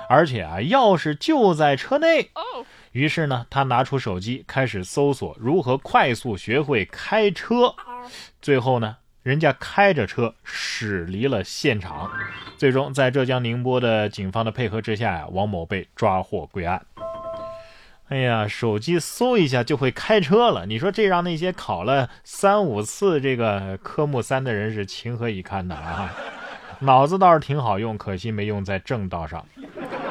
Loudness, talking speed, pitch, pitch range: -22 LUFS, 235 characters per minute, 130 Hz, 110-170 Hz